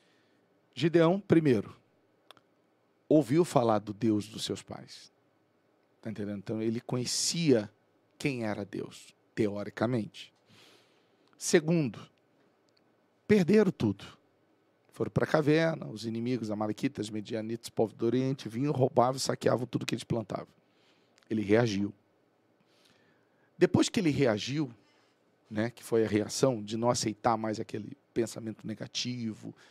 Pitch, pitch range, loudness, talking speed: 115 Hz, 105-135 Hz, -30 LUFS, 120 wpm